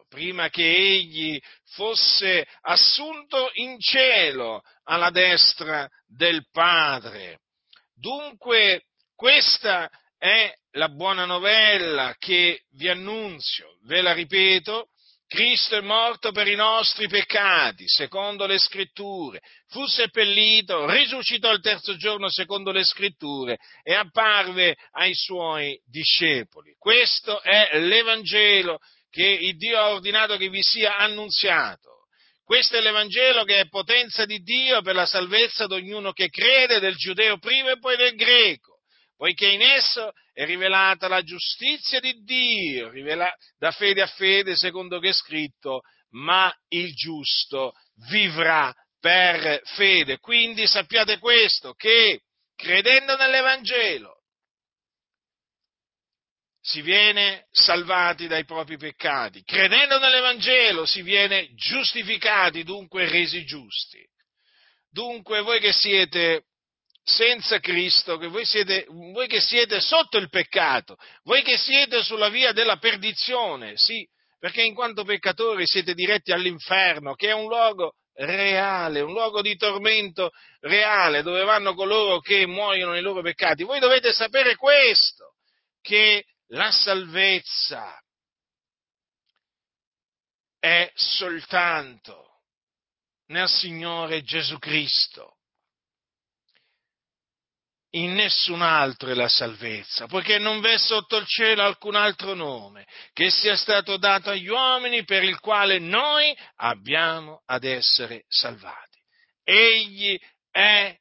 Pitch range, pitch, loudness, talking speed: 175-225 Hz, 200 Hz, -20 LUFS, 115 wpm